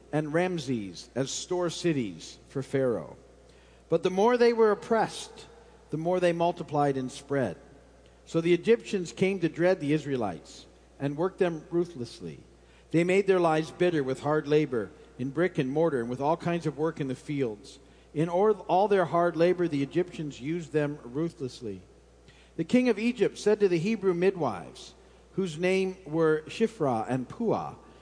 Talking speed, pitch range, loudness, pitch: 165 wpm, 135-180 Hz, -28 LUFS, 160 Hz